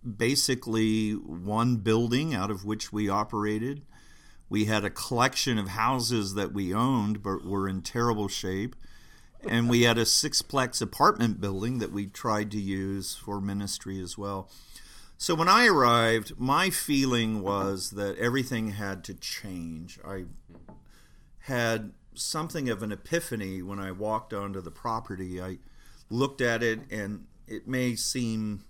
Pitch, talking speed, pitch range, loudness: 105 Hz, 145 wpm, 100-120 Hz, -28 LUFS